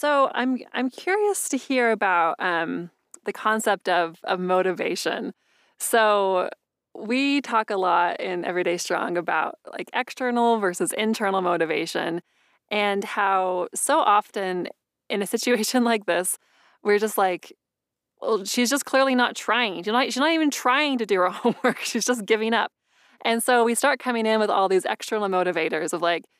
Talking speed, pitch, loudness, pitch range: 165 wpm, 215 Hz, -23 LUFS, 185-245 Hz